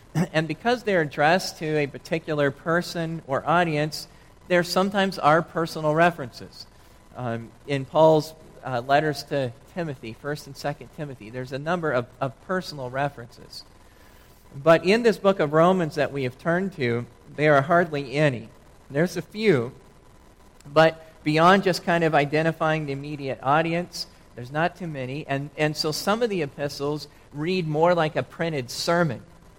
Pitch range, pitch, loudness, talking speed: 135-170 Hz, 150 Hz, -24 LUFS, 155 wpm